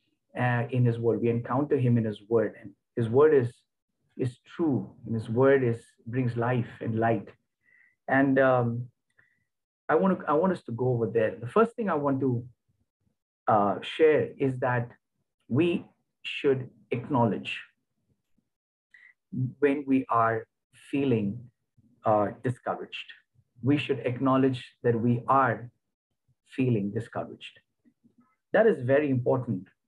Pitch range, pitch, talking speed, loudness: 115-135 Hz, 125 Hz, 135 wpm, -27 LUFS